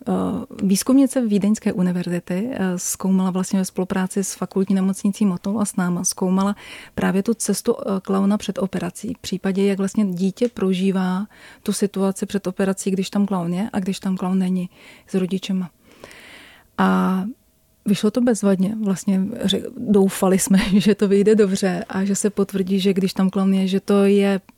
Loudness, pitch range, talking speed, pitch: -20 LUFS, 190-205 Hz, 160 wpm, 195 Hz